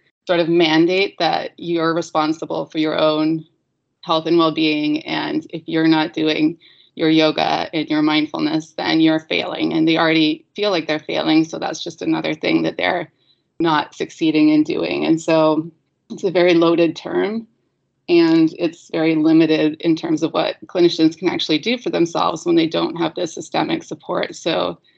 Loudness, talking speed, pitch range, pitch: -18 LUFS, 175 wpm, 160-240 Hz, 165 Hz